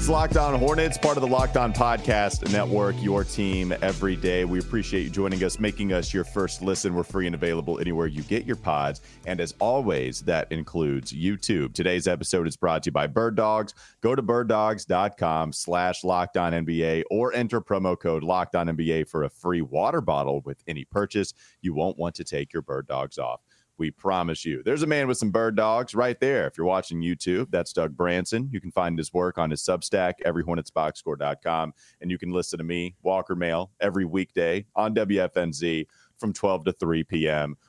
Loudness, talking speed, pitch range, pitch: -26 LUFS, 200 wpm, 85-105 Hz, 90 Hz